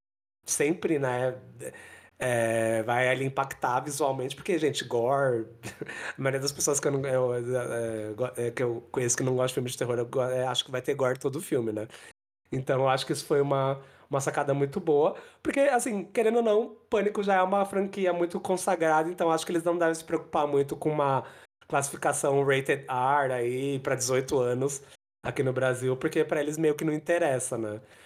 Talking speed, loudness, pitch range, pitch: 190 wpm, -28 LUFS, 125-165 Hz, 140 Hz